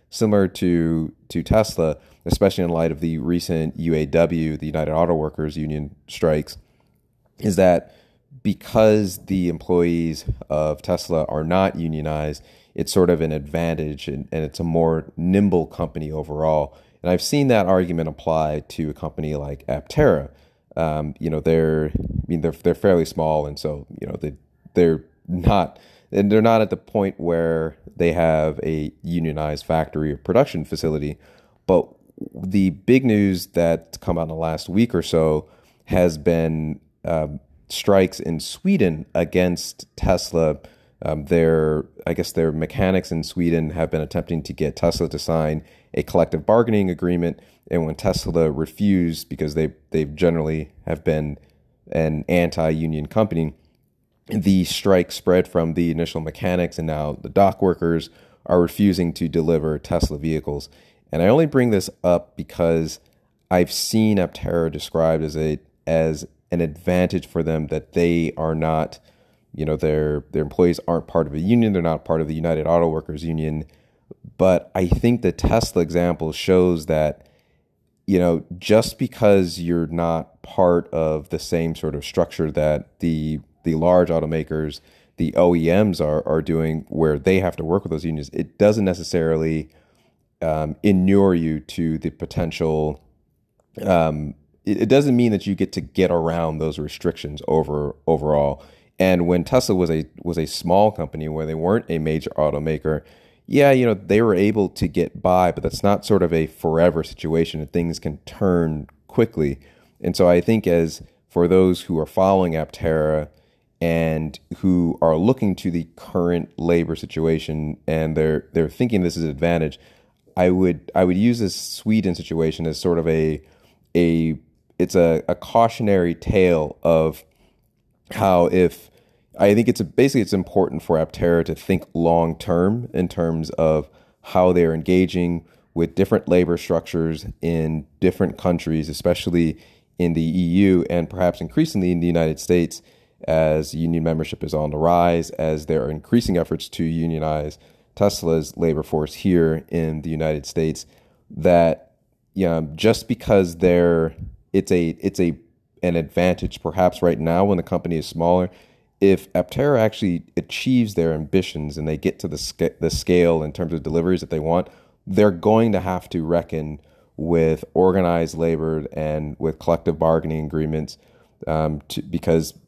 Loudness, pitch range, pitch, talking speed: -21 LUFS, 80-90 Hz, 80 Hz, 160 wpm